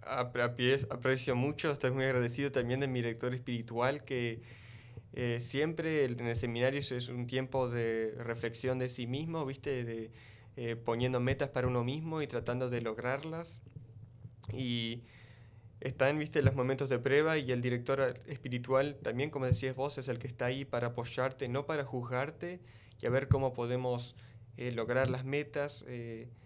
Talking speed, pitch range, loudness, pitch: 170 wpm, 120-135 Hz, -35 LUFS, 125 Hz